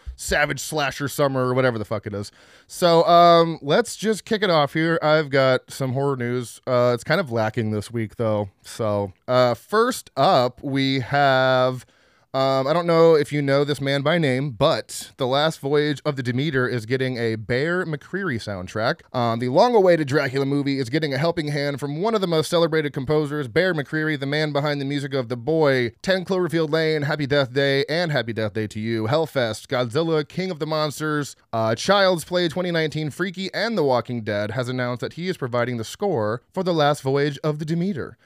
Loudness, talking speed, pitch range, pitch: -22 LUFS, 205 wpm, 125-160 Hz, 140 Hz